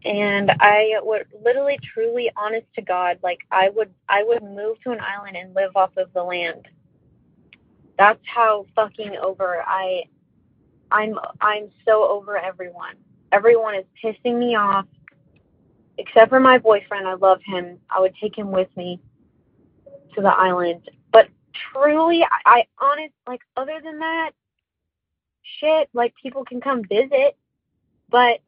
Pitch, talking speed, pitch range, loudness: 215 Hz, 150 wpm, 190-250 Hz, -19 LUFS